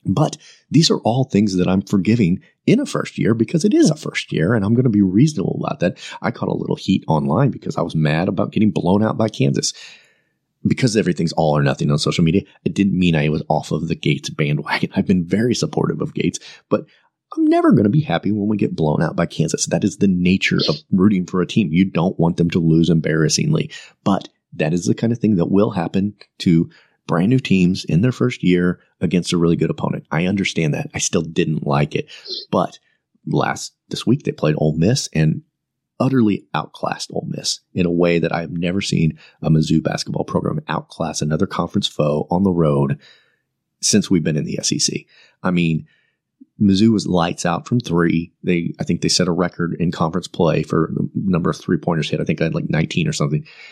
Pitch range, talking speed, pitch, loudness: 80-105 Hz, 220 wpm, 90 Hz, -19 LUFS